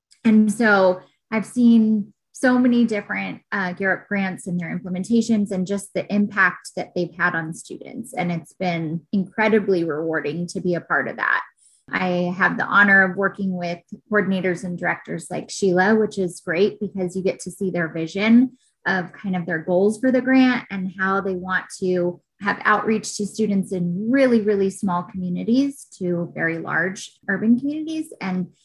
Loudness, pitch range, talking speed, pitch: -21 LUFS, 180-215 Hz, 175 wpm, 195 Hz